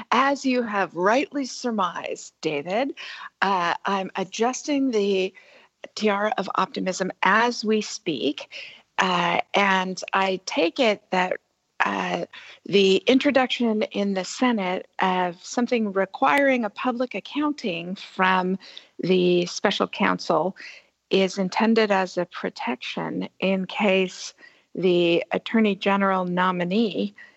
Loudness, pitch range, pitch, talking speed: -23 LUFS, 185-245 Hz, 200 Hz, 105 wpm